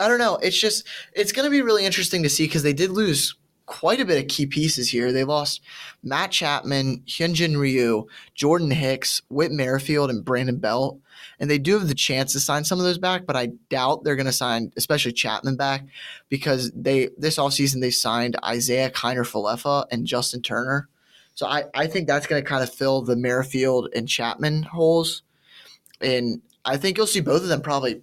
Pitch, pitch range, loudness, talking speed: 140 Hz, 125-155 Hz, -22 LUFS, 205 wpm